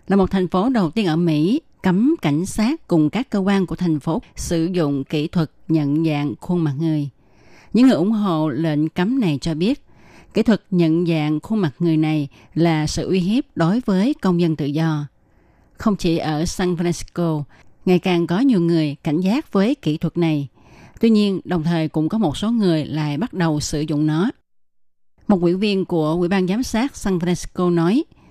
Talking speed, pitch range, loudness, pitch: 205 wpm, 155-195 Hz, -20 LUFS, 170 Hz